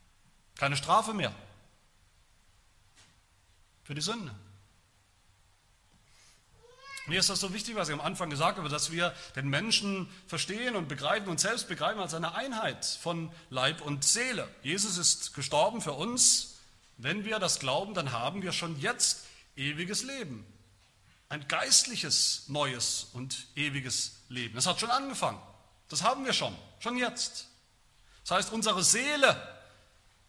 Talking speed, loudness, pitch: 140 wpm, -30 LUFS, 150 Hz